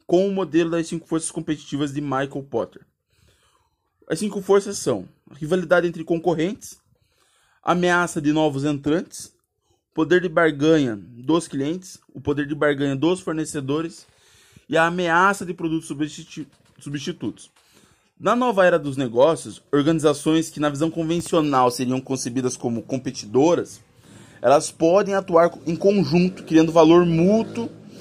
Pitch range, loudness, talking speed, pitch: 145-175 Hz, -21 LUFS, 135 wpm, 160 Hz